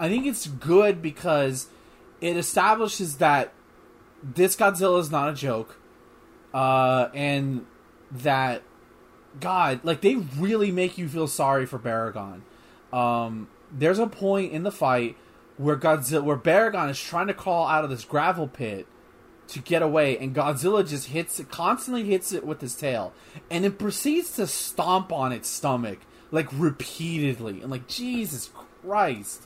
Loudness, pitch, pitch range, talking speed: -25 LUFS, 155 Hz, 130-185 Hz, 155 wpm